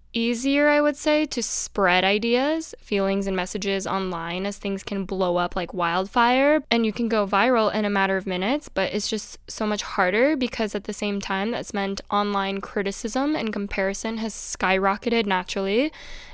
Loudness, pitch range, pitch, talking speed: -23 LUFS, 195-235 Hz, 205 Hz, 175 wpm